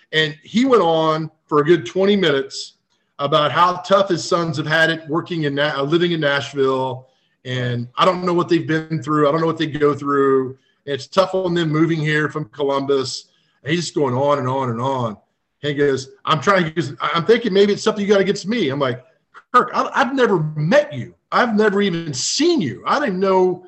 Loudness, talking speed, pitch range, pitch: -18 LUFS, 215 wpm, 140-185 Hz, 160 Hz